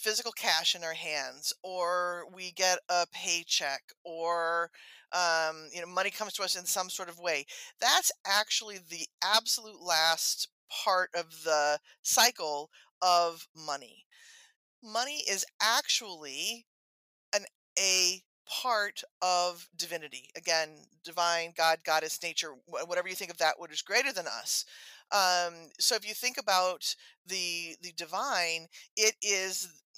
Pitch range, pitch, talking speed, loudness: 165-200 Hz, 180 Hz, 135 wpm, -30 LUFS